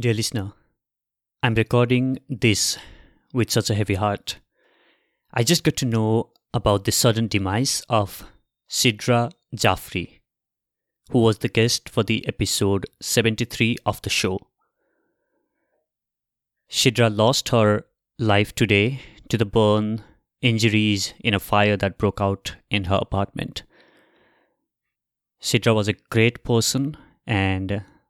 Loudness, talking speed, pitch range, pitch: -21 LUFS, 120 wpm, 105-120 Hz, 115 Hz